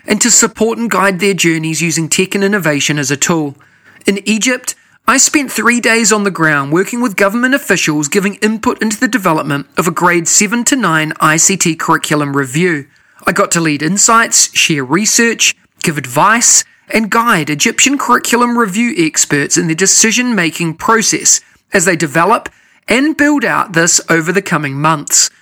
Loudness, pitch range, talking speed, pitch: -11 LUFS, 165-230 Hz, 170 wpm, 200 Hz